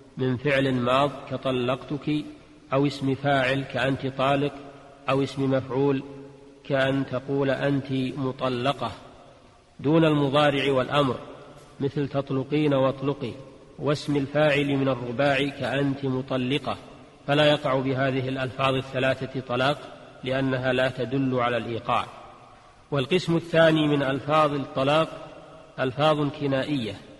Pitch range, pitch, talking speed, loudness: 130-145 Hz, 135 Hz, 100 wpm, -25 LUFS